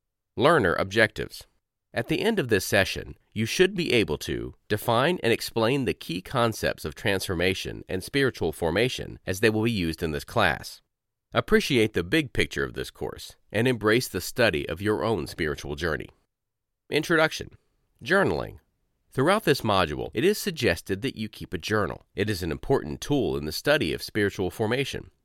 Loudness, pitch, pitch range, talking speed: -26 LUFS, 110 Hz, 95-125 Hz, 170 wpm